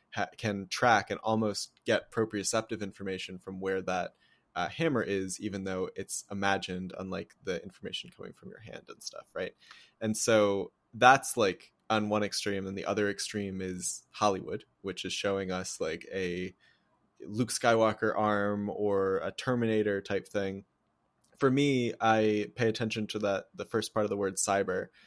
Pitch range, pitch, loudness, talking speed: 95-110 Hz, 100 Hz, -31 LUFS, 165 wpm